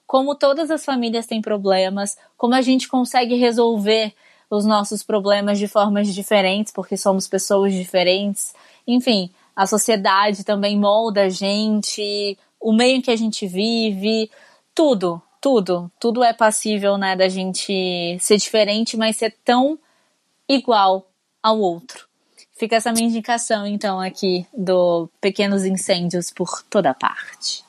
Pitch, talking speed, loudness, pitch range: 210 Hz, 135 wpm, -19 LUFS, 195-230 Hz